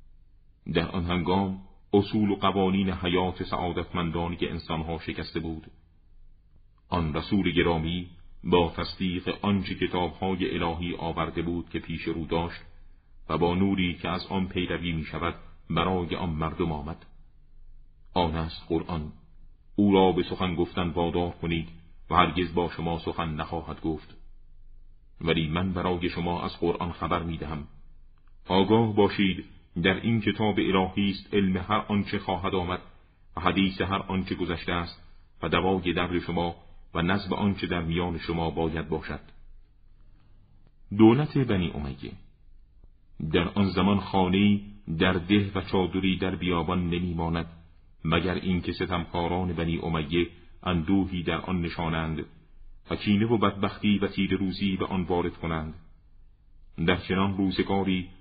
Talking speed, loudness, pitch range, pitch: 135 wpm, -27 LUFS, 85-95 Hz, 90 Hz